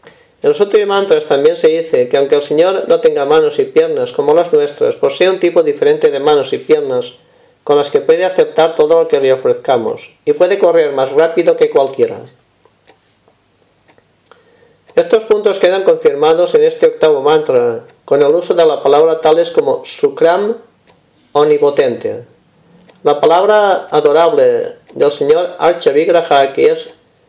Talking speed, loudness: 155 wpm, -12 LUFS